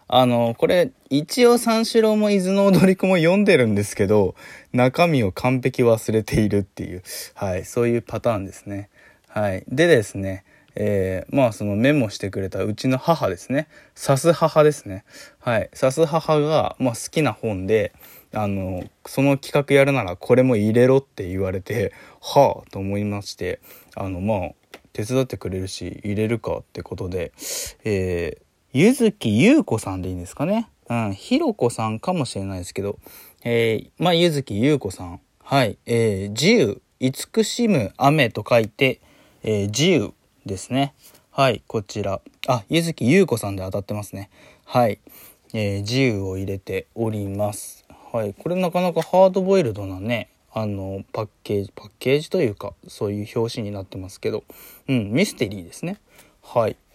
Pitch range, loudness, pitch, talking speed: 100-145 Hz, -21 LUFS, 115 Hz, 330 characters per minute